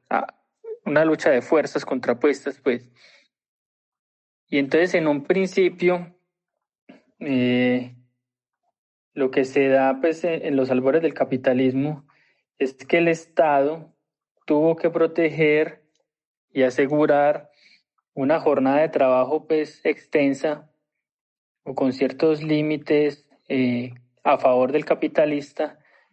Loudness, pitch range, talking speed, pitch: -21 LUFS, 135-160 Hz, 105 wpm, 150 Hz